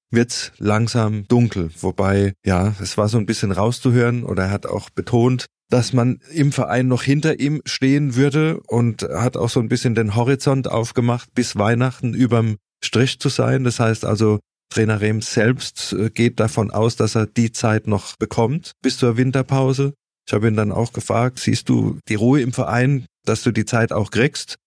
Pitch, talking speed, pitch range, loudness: 120 Hz, 185 wpm, 110-130 Hz, -19 LUFS